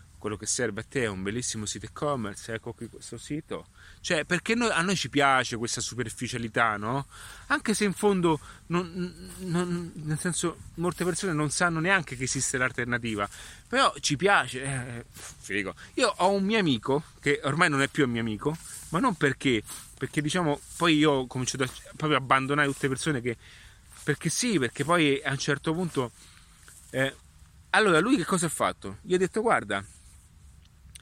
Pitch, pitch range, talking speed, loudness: 135 Hz, 115-165 Hz, 185 wpm, -27 LUFS